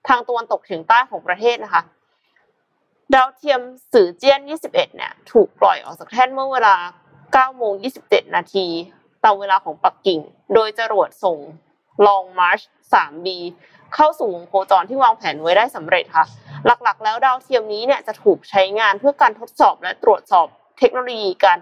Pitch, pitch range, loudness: 215 Hz, 185-260 Hz, -17 LUFS